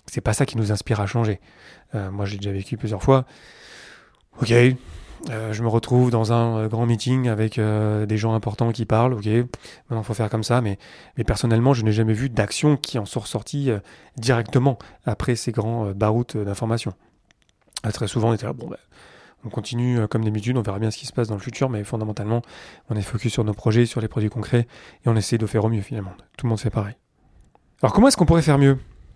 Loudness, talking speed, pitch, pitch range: -22 LUFS, 230 wpm, 115 Hz, 110-120 Hz